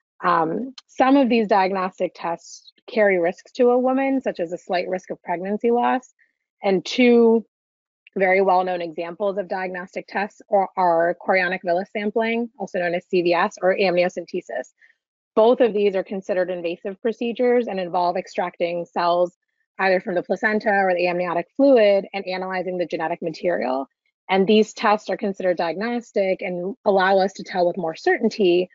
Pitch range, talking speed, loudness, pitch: 180-220 Hz, 160 wpm, -21 LUFS, 190 Hz